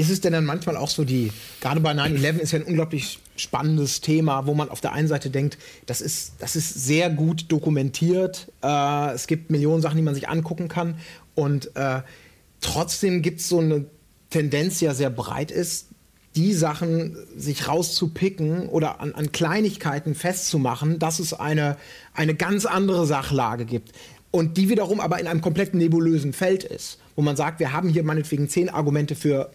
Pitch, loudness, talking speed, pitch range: 155 Hz, -23 LUFS, 185 wpm, 145-170 Hz